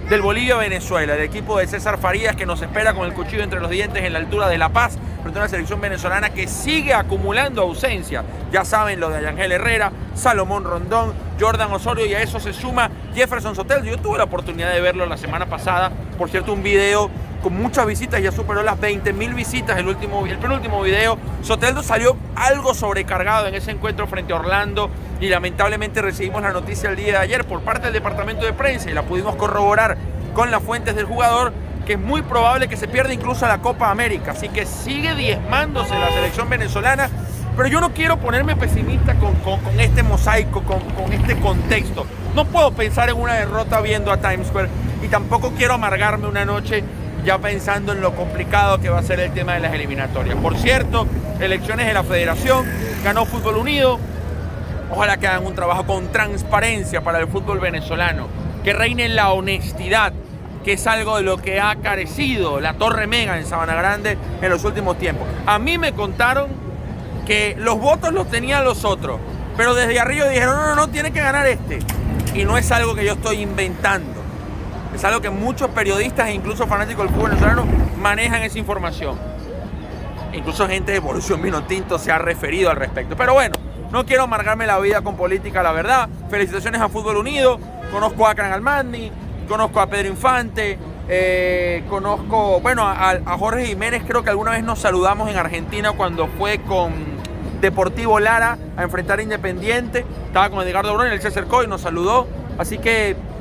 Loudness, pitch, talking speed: -19 LUFS, 200 Hz, 190 wpm